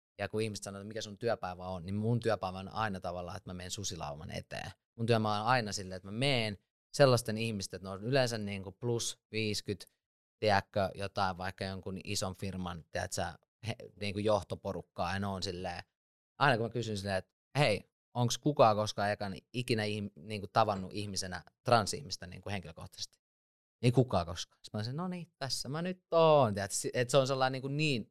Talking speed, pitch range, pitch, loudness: 175 wpm, 95-115 Hz, 105 Hz, -34 LUFS